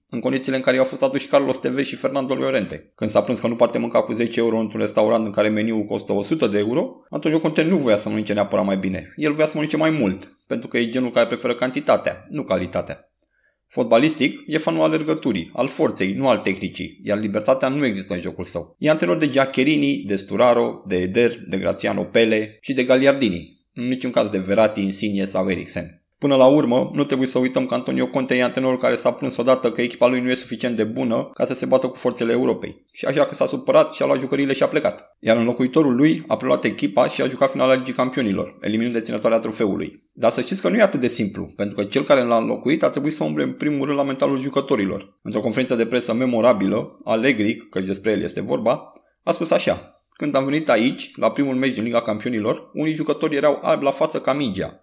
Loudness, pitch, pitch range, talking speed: -20 LUFS, 120 Hz, 105-135 Hz, 230 wpm